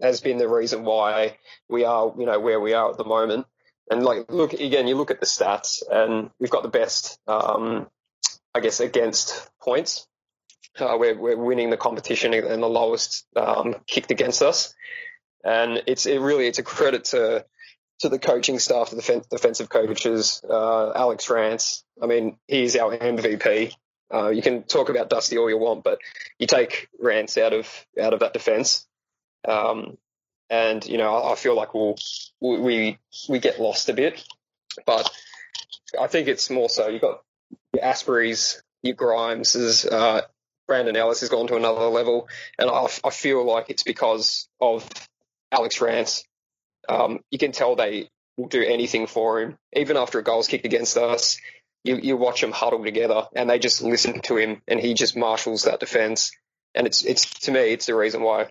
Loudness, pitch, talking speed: -22 LUFS, 120 Hz, 185 wpm